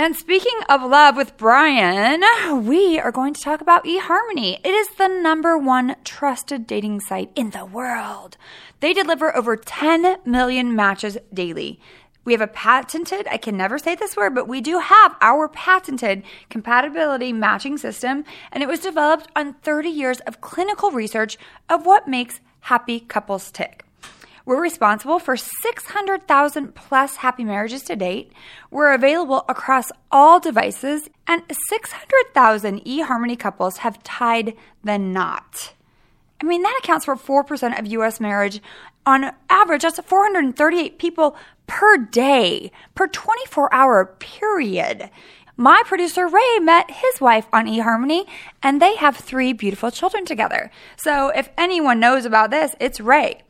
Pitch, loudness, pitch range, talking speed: 280 Hz, -18 LUFS, 235-340 Hz, 145 wpm